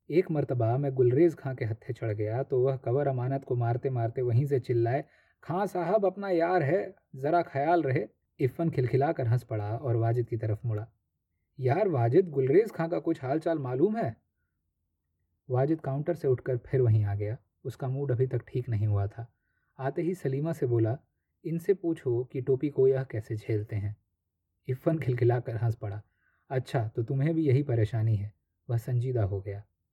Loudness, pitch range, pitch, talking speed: -29 LUFS, 110-140 Hz, 125 Hz, 185 wpm